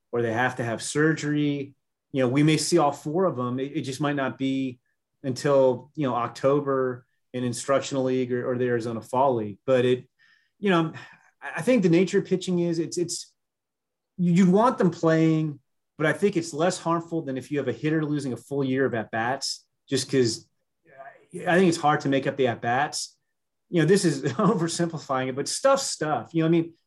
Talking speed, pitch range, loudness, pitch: 210 wpm, 130-170 Hz, -25 LUFS, 145 Hz